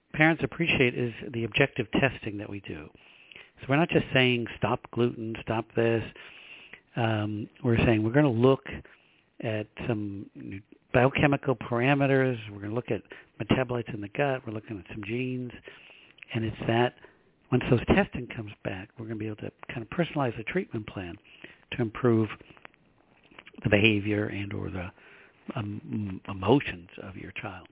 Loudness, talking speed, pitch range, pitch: -28 LUFS, 160 wpm, 105-130 Hz, 115 Hz